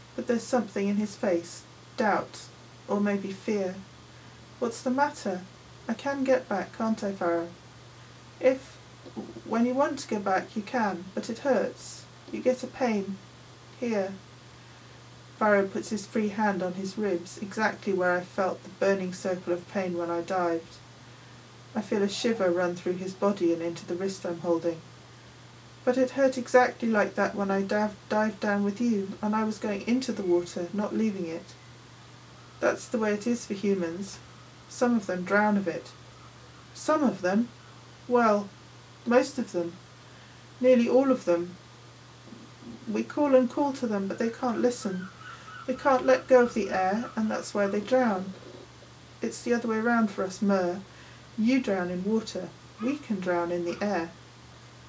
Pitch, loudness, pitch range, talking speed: 205 Hz, -28 LUFS, 185-240 Hz, 170 wpm